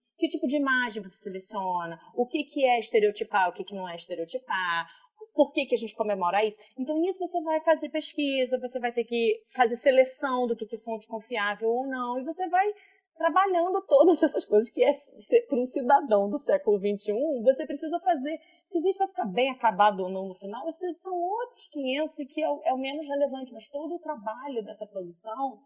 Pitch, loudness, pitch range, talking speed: 265 Hz, -27 LUFS, 220-320 Hz, 200 wpm